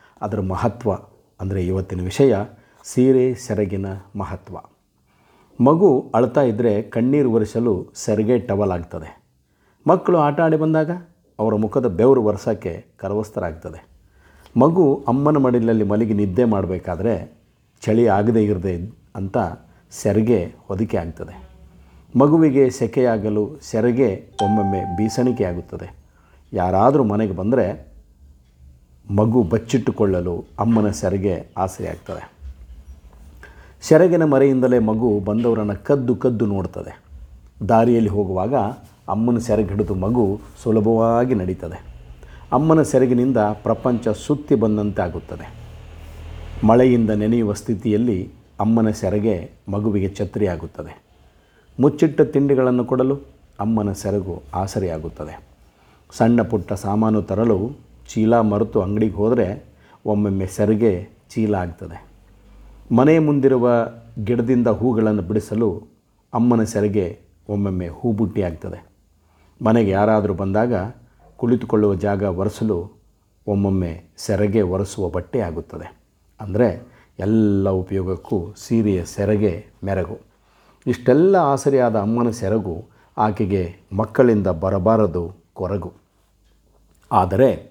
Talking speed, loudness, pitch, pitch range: 90 wpm, -19 LUFS, 105 Hz, 95-115 Hz